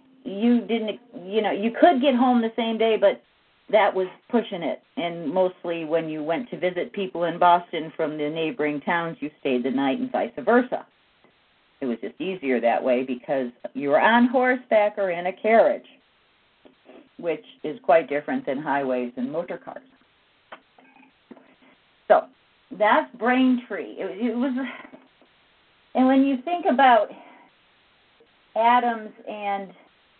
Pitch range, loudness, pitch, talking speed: 160-250 Hz, -23 LUFS, 205 Hz, 145 wpm